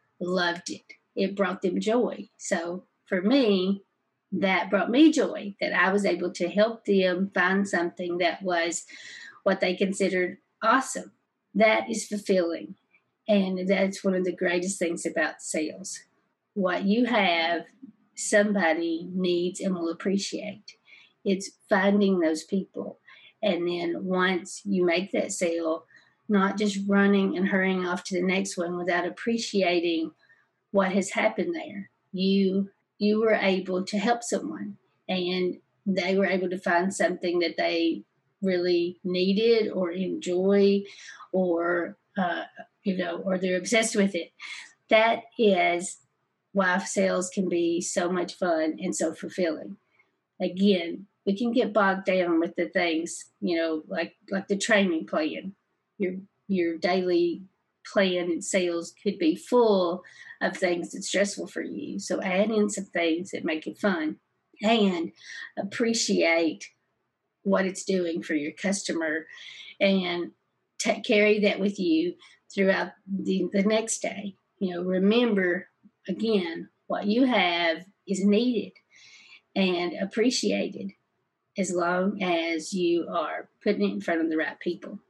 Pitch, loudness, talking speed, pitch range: 190 Hz, -26 LUFS, 140 wpm, 175-205 Hz